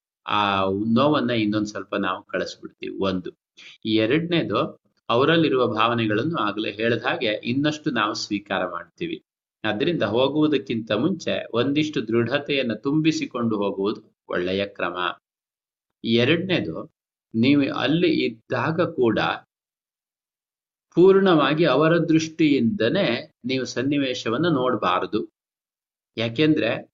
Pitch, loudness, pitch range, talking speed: 125 Hz, -22 LUFS, 105-155 Hz, 80 wpm